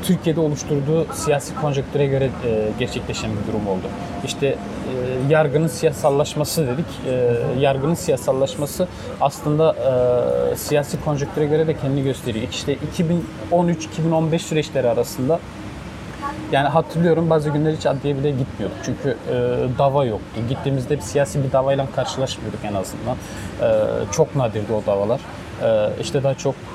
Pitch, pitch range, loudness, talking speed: 140 Hz, 125-155 Hz, -21 LUFS, 130 wpm